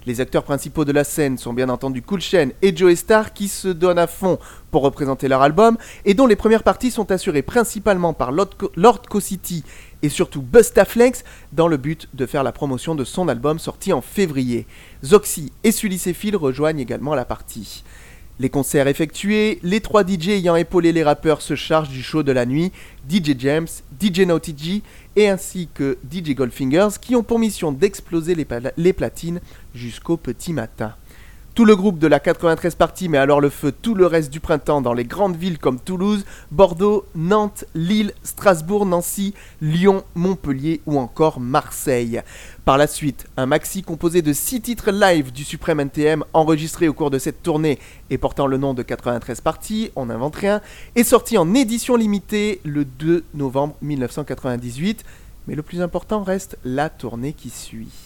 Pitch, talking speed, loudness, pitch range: 160 Hz, 185 wpm, -19 LUFS, 140-195 Hz